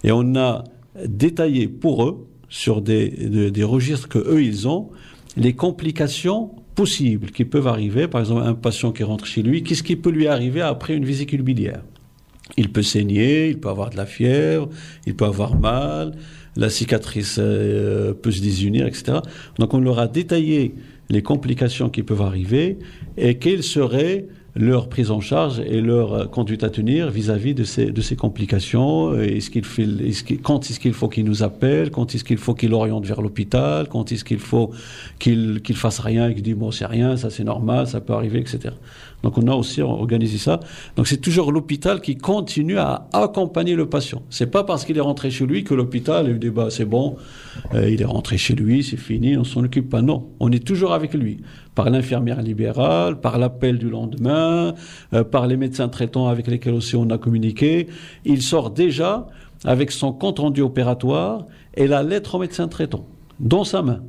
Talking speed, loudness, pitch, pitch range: 195 wpm, -20 LUFS, 125 Hz, 110-145 Hz